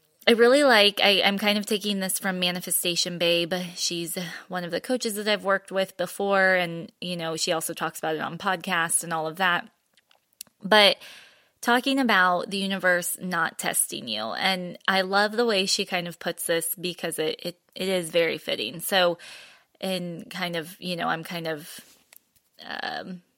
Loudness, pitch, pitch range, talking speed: -24 LUFS, 180 Hz, 170-200 Hz, 180 wpm